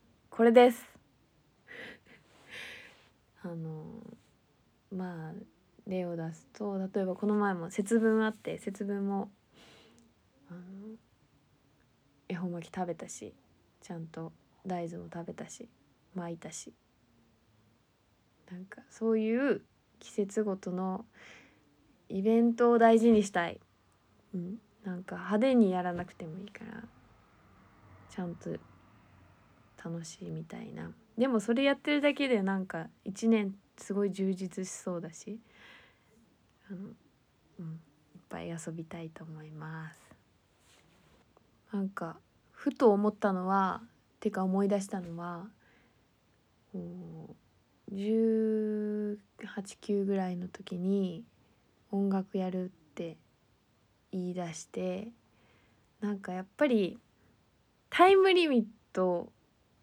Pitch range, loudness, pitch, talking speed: 165-210 Hz, -32 LUFS, 185 Hz, 200 characters per minute